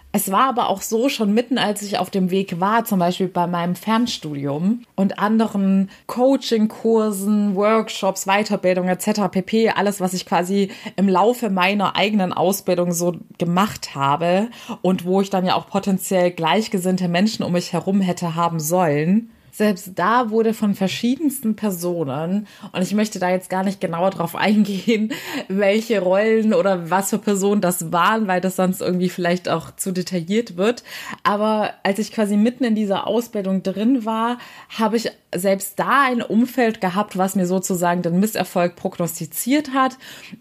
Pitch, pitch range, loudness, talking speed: 195 Hz, 180-220 Hz, -20 LUFS, 160 wpm